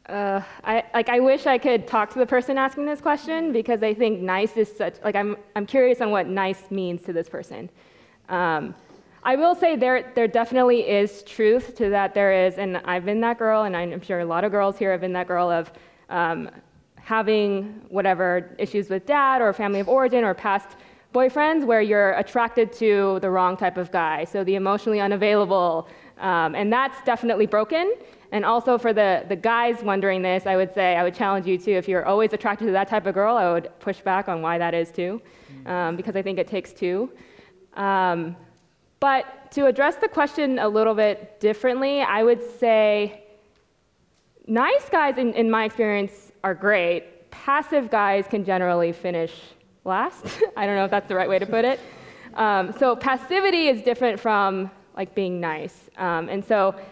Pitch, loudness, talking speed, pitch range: 205 Hz, -22 LUFS, 195 wpm, 190-235 Hz